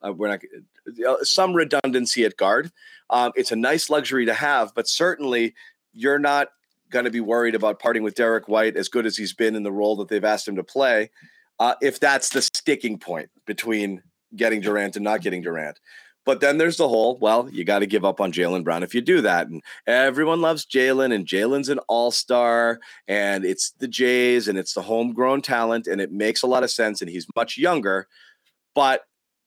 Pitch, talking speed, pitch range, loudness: 120 Hz, 210 wpm, 105-140 Hz, -21 LUFS